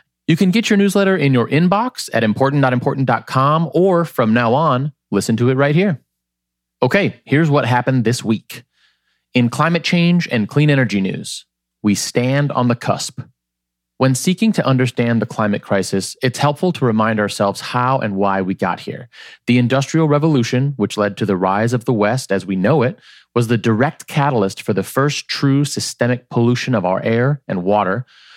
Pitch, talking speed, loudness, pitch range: 125 Hz, 180 wpm, -17 LUFS, 105-145 Hz